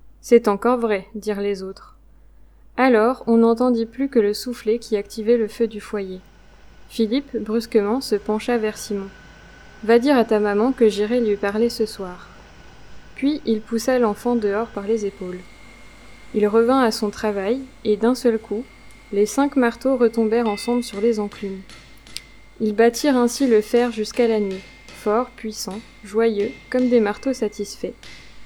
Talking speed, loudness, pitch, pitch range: 160 wpm, -20 LUFS, 225 Hz, 210-240 Hz